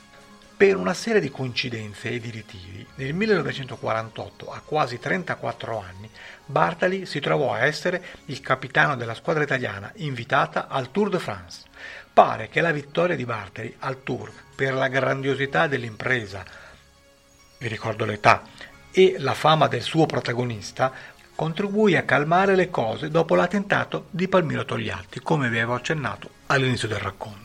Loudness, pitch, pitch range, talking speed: -23 LUFS, 130 Hz, 110-160 Hz, 145 wpm